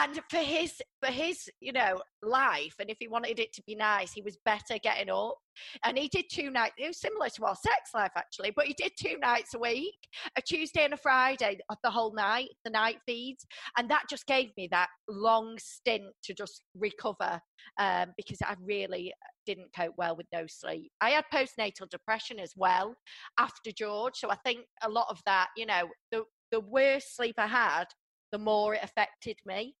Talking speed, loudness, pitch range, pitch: 205 wpm, -31 LUFS, 205-260 Hz, 225 Hz